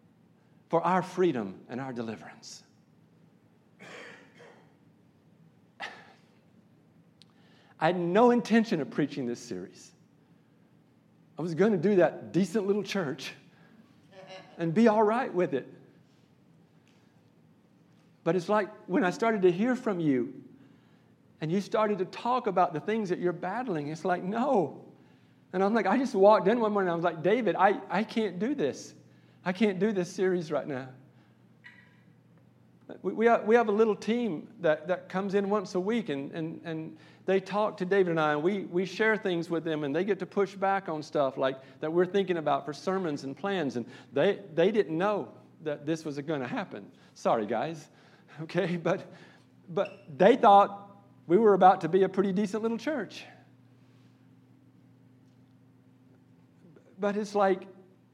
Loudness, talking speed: -28 LUFS, 160 wpm